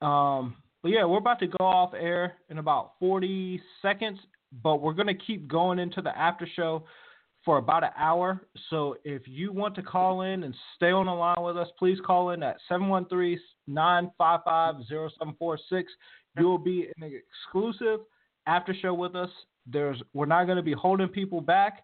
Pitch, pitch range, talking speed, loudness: 180 Hz, 160-185 Hz, 180 wpm, -28 LUFS